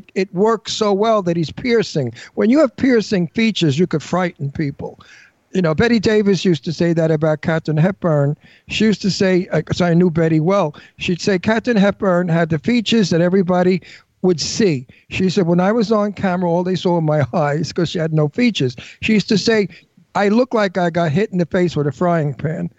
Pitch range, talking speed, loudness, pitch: 160-205 Hz, 220 wpm, -17 LUFS, 180 Hz